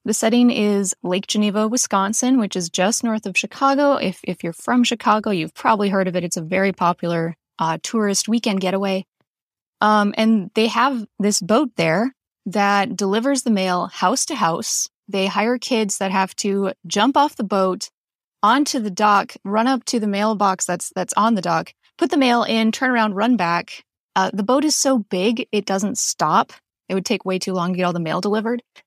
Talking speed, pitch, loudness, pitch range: 200 wpm, 205 Hz, -19 LUFS, 190-235 Hz